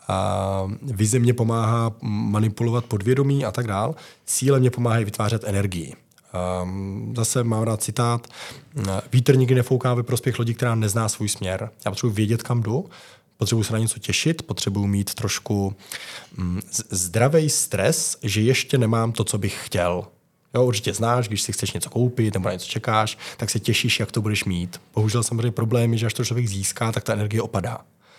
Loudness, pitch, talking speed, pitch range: -23 LUFS, 115 Hz, 180 wpm, 105-125 Hz